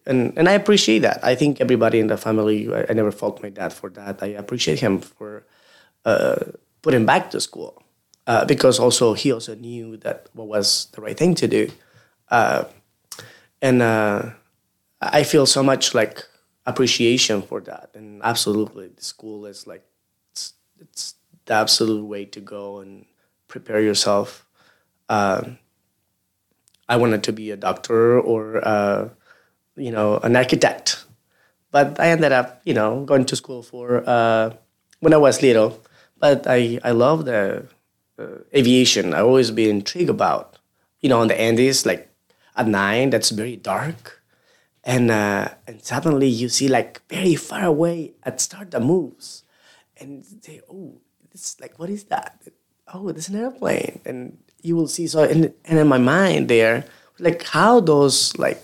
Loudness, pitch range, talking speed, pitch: -19 LUFS, 110-145 Hz, 165 wpm, 120 Hz